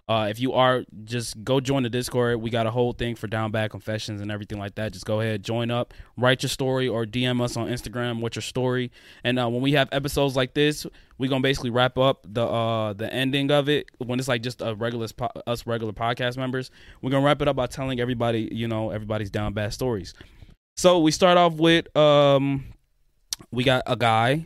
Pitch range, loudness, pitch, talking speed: 110-130 Hz, -24 LUFS, 120 Hz, 225 wpm